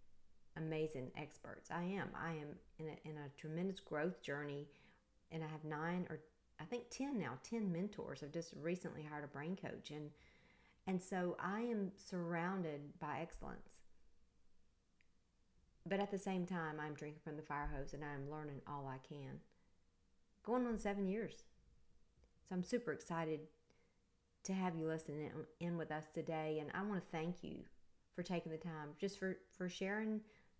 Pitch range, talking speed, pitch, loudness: 145-185 Hz, 170 wpm, 160 Hz, -46 LUFS